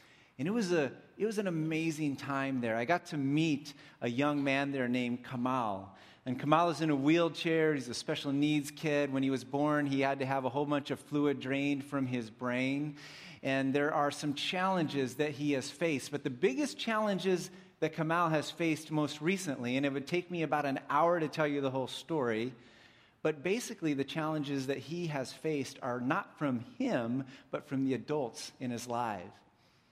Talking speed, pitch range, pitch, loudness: 200 wpm, 135-160 Hz, 145 Hz, -34 LUFS